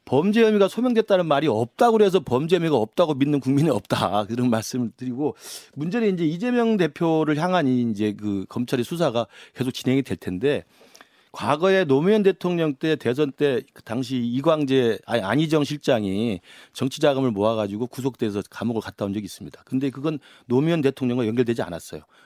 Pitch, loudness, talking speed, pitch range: 135 Hz, -22 LUFS, 380 characters per minute, 120-165 Hz